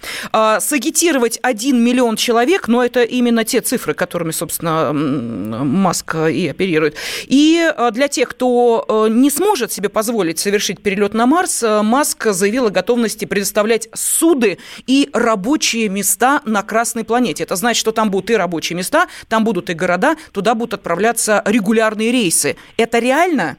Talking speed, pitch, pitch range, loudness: 145 wpm, 230 Hz, 205-250 Hz, -15 LUFS